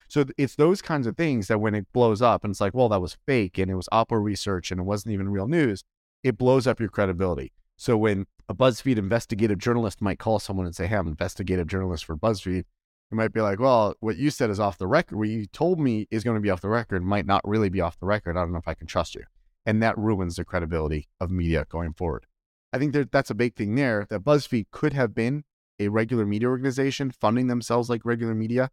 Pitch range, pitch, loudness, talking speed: 95-120 Hz, 110 Hz, -25 LUFS, 250 wpm